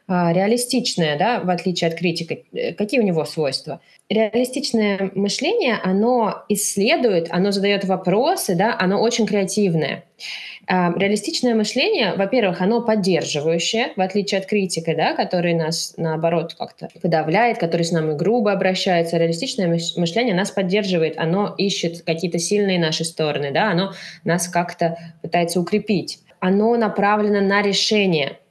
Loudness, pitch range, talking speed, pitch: -20 LUFS, 170-210 Hz, 130 wpm, 190 Hz